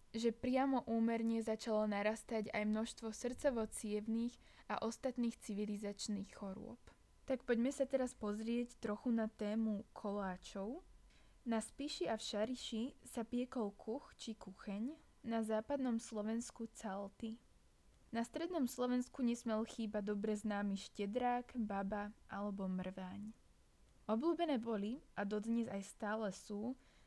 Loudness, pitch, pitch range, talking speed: -42 LUFS, 225 Hz, 210-245 Hz, 115 wpm